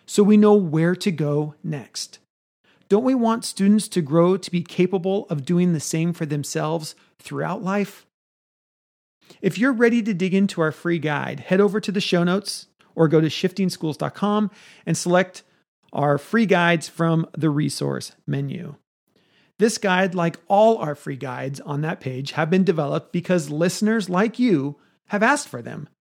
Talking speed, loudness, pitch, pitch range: 170 wpm, -21 LUFS, 180 Hz, 155-200 Hz